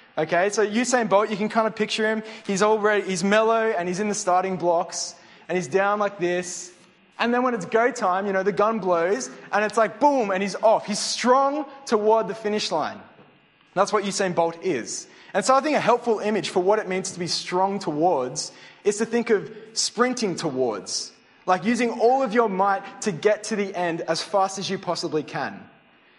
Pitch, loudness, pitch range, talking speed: 205 Hz, -23 LUFS, 185-220 Hz, 215 wpm